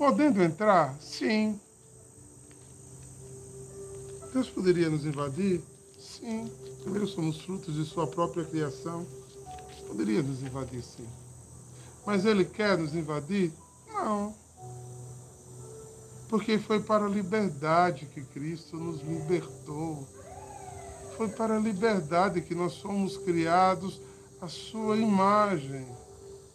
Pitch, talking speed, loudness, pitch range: 165 Hz, 105 wpm, -29 LUFS, 130-200 Hz